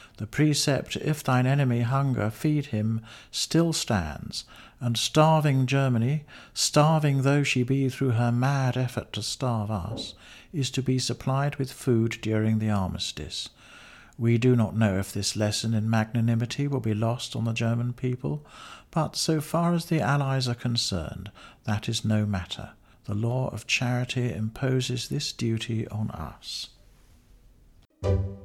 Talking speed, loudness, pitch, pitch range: 150 wpm, -26 LUFS, 120 Hz, 110-135 Hz